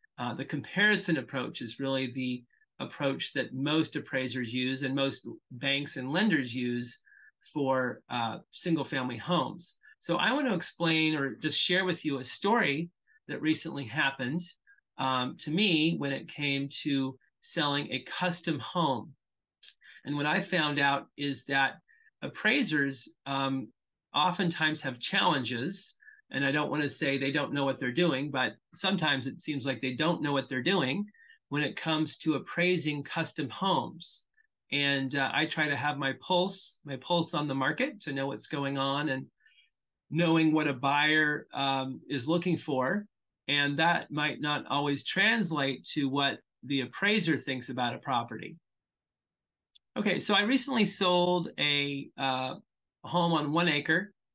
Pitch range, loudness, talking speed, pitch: 135-175 Hz, -30 LUFS, 160 wpm, 150 Hz